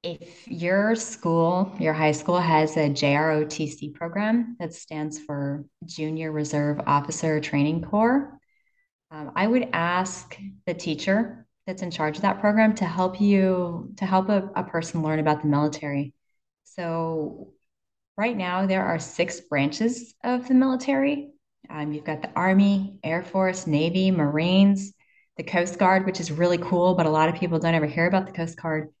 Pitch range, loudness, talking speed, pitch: 155-195 Hz, -24 LUFS, 165 wpm, 175 Hz